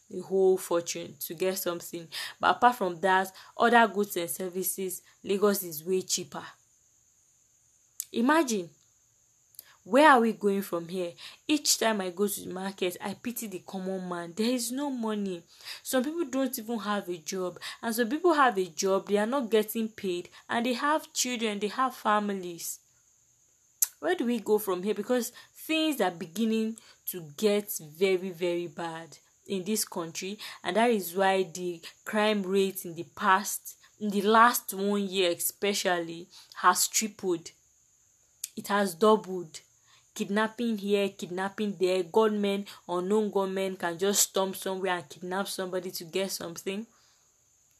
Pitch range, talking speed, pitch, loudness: 180-220 Hz, 155 wpm, 195 Hz, -29 LUFS